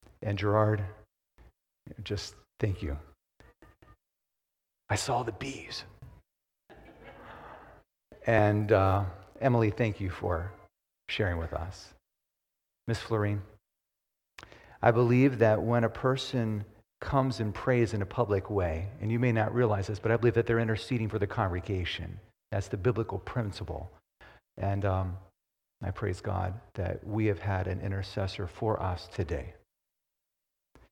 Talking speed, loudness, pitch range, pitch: 130 wpm, -30 LUFS, 95-115 Hz, 105 Hz